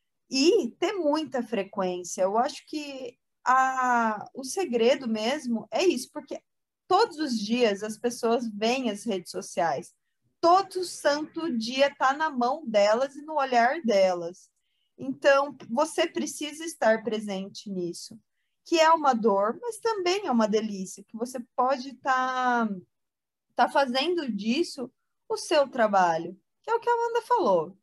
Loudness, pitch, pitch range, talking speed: -26 LUFS, 255 Hz, 220-310 Hz, 140 wpm